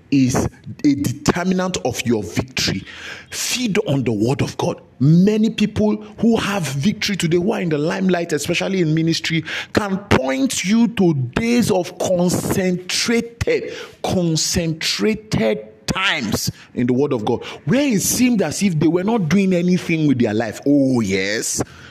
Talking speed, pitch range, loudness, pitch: 150 wpm, 140-210 Hz, -19 LUFS, 175 Hz